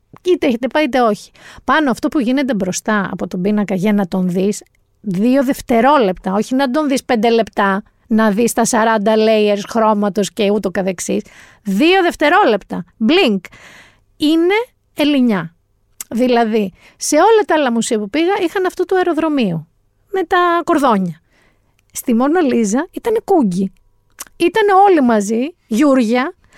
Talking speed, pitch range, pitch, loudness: 145 wpm, 205-310 Hz, 235 Hz, -15 LUFS